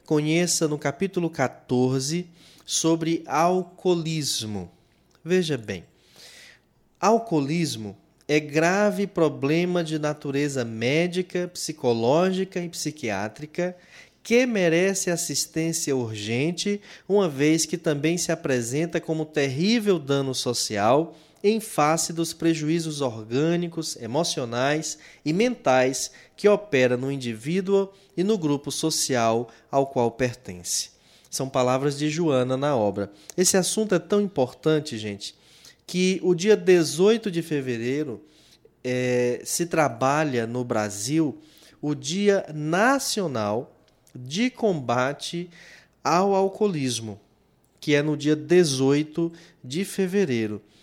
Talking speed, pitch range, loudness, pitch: 105 wpm, 130-175 Hz, -24 LUFS, 155 Hz